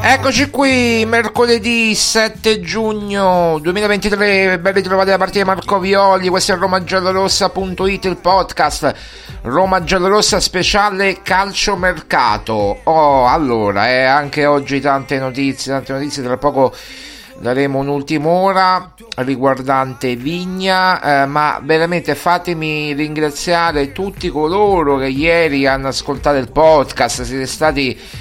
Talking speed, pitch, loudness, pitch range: 115 wpm, 175 Hz, -14 LUFS, 140-195 Hz